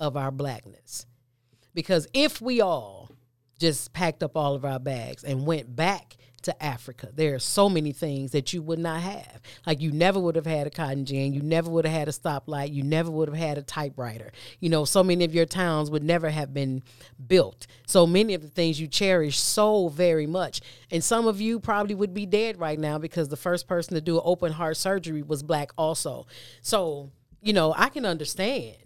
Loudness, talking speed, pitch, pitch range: -26 LUFS, 215 wpm, 155 Hz, 135-175 Hz